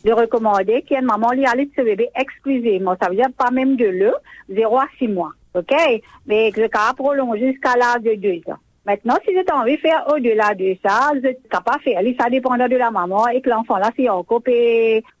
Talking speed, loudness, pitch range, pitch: 240 wpm, -18 LUFS, 220-265 Hz, 245 Hz